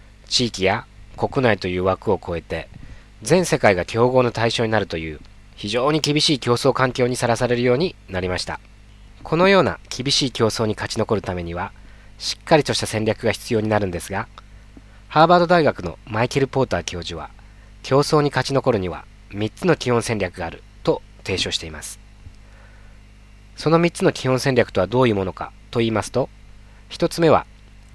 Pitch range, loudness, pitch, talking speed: 100-125 Hz, -20 LUFS, 105 Hz, 345 characters per minute